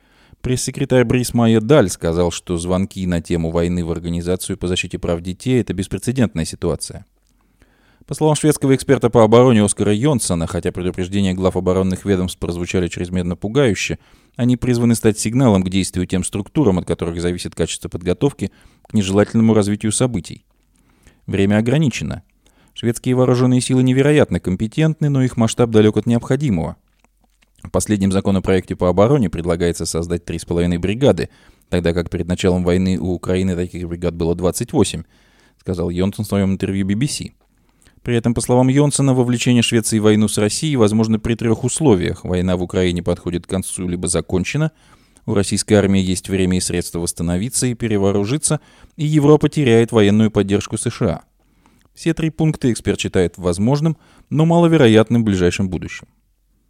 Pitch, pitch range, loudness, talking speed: 100 Hz, 90-120 Hz, -17 LUFS, 150 wpm